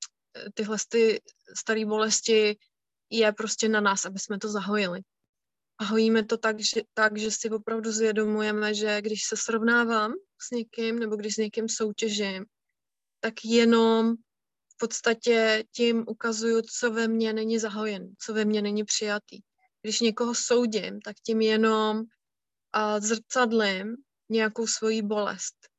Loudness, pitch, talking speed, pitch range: -26 LUFS, 220 Hz, 135 wpm, 215-230 Hz